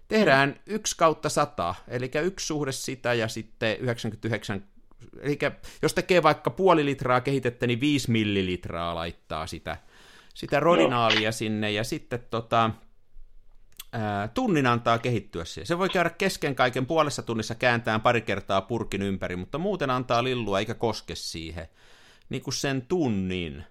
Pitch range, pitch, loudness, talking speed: 100-140 Hz, 115 Hz, -26 LUFS, 145 wpm